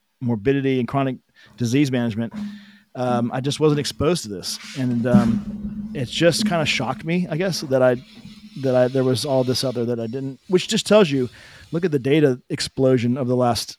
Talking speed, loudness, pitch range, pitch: 200 wpm, -21 LUFS, 125-180 Hz, 135 Hz